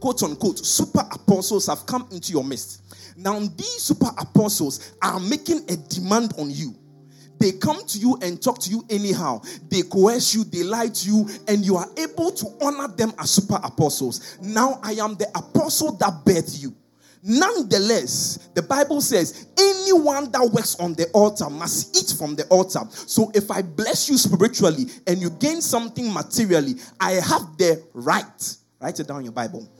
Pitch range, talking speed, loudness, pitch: 170-240 Hz, 180 wpm, -21 LUFS, 200 Hz